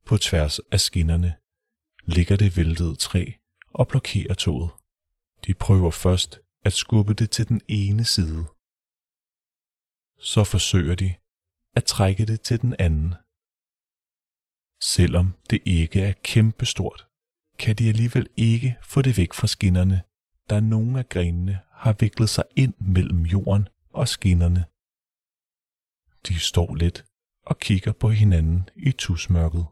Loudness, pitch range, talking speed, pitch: -22 LUFS, 85-110 Hz, 130 wpm, 95 Hz